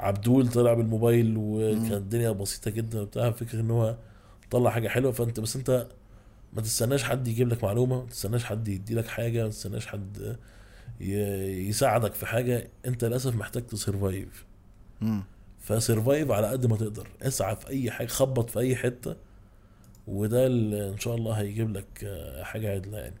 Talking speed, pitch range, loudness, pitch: 160 wpm, 100-120 Hz, -28 LUFS, 110 Hz